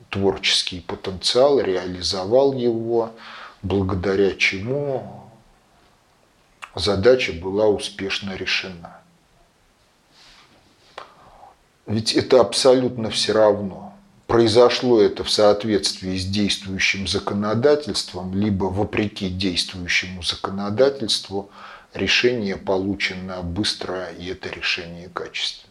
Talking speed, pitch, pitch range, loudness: 75 wpm, 100 Hz, 95-110 Hz, -20 LUFS